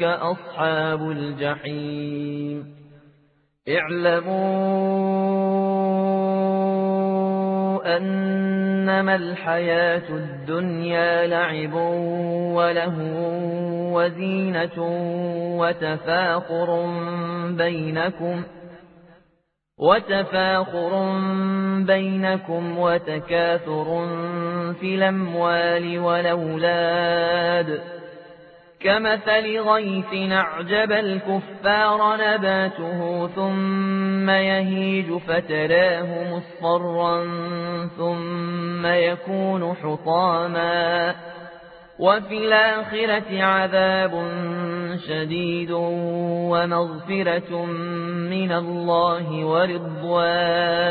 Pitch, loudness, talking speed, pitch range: 175 Hz, -22 LUFS, 45 wpm, 170-190 Hz